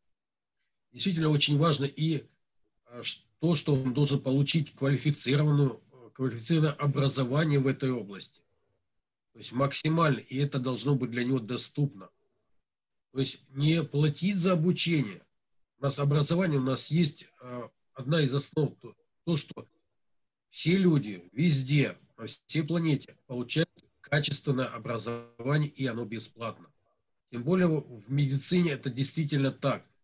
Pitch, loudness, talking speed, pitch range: 140 Hz, -29 LUFS, 125 wpm, 130-155 Hz